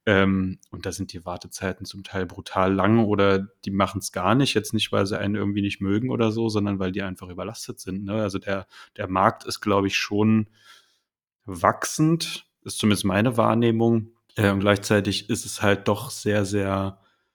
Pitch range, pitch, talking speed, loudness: 95-110 Hz, 100 Hz, 190 wpm, -24 LUFS